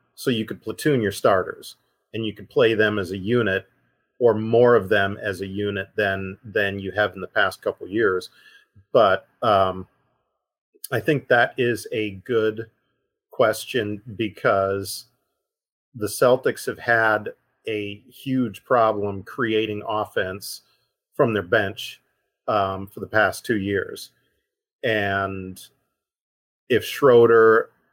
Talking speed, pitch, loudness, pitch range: 135 wpm, 110 Hz, -22 LUFS, 100-120 Hz